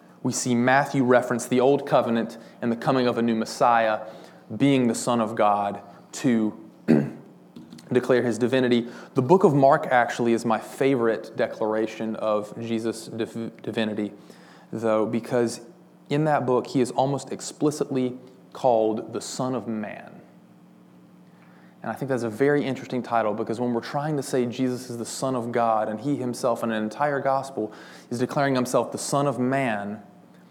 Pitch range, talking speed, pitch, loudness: 110-130 Hz, 165 wpm, 120 Hz, -24 LUFS